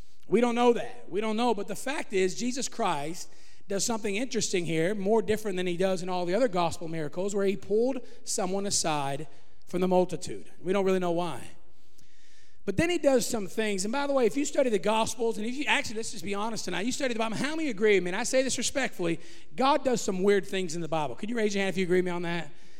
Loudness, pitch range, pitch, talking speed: -29 LUFS, 180-235 Hz, 205 Hz, 260 wpm